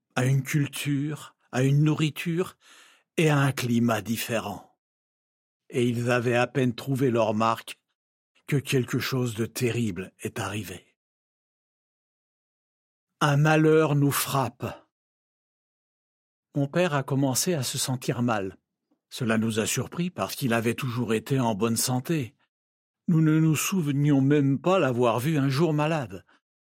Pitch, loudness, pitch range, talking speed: 130 Hz, -25 LUFS, 115-150 Hz, 135 wpm